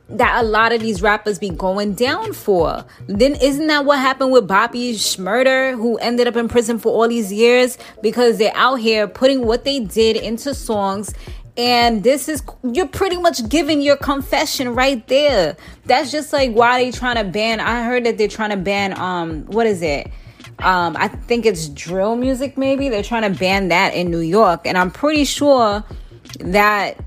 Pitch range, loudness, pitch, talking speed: 210-265 Hz, -16 LUFS, 235 Hz, 195 wpm